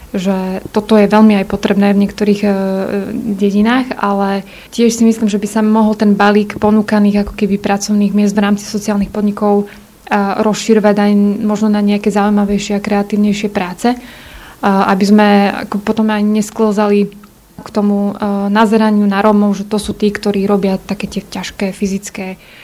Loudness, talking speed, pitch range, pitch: -13 LUFS, 150 wpm, 200-215 Hz, 205 Hz